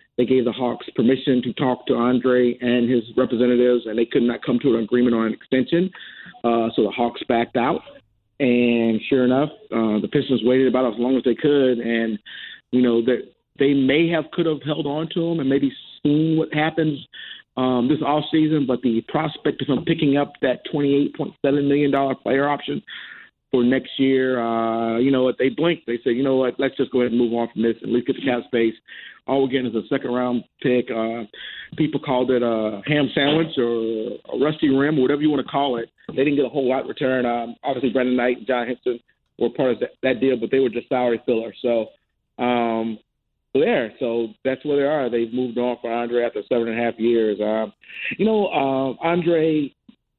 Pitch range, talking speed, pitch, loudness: 120-140 Hz, 225 wpm, 125 Hz, -21 LUFS